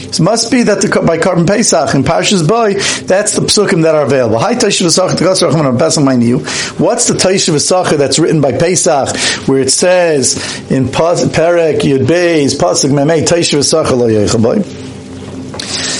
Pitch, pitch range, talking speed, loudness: 165 Hz, 140-190 Hz, 180 wpm, -10 LUFS